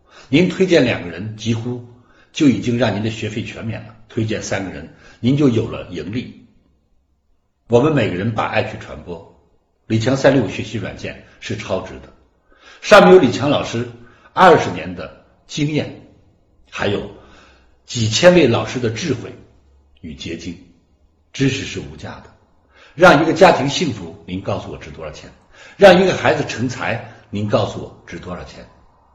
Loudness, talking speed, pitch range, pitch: -16 LUFS, 235 characters per minute, 85-120 Hz, 105 Hz